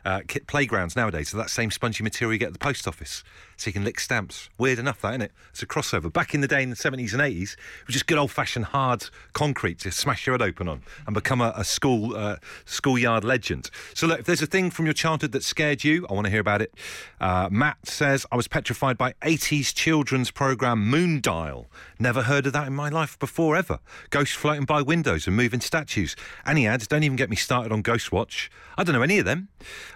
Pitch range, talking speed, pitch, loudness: 110-150 Hz, 240 wpm, 125 Hz, -24 LUFS